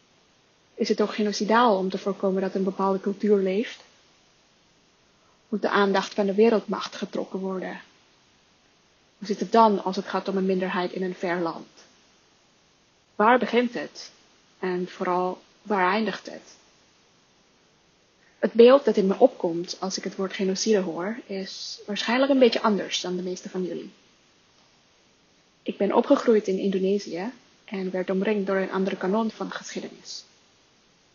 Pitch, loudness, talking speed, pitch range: 195 Hz, -24 LUFS, 150 wpm, 190-215 Hz